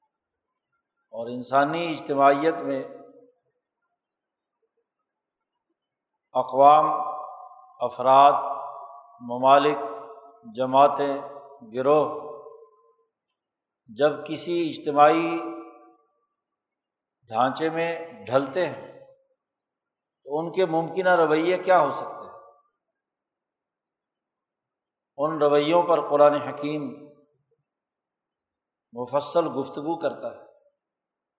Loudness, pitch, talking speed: -22 LUFS, 155 Hz, 65 wpm